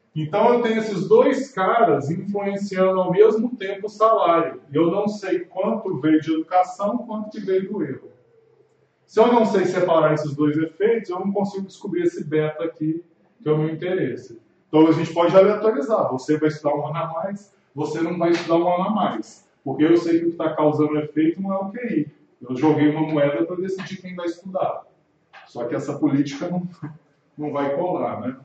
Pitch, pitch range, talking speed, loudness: 175 Hz, 155-200 Hz, 200 wpm, -21 LUFS